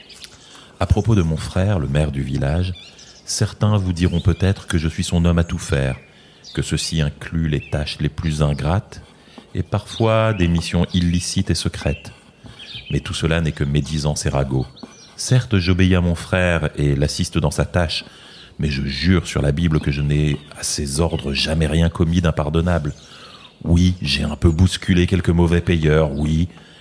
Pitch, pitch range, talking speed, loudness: 85 Hz, 75-90 Hz, 175 wpm, -19 LUFS